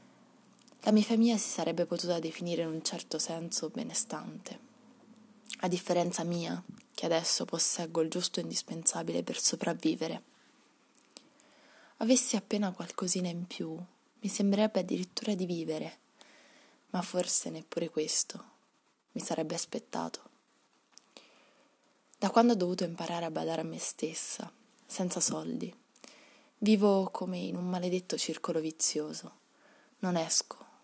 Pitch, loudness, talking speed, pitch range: 200 Hz, -30 LUFS, 120 wpm, 175-235 Hz